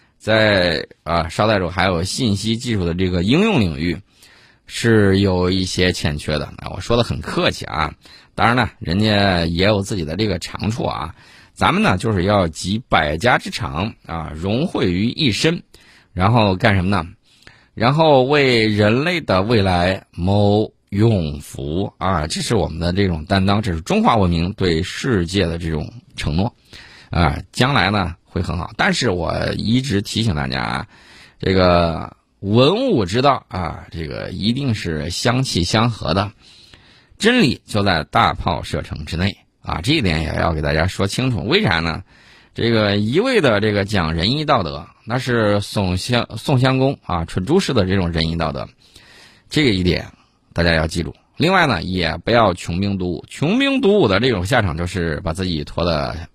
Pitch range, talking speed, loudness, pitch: 85-115 Hz, 245 characters per minute, -18 LUFS, 100 Hz